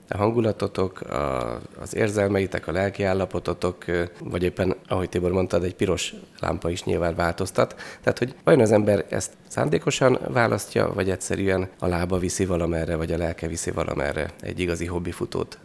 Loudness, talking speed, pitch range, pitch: -25 LUFS, 155 wpm, 85-95 Hz, 90 Hz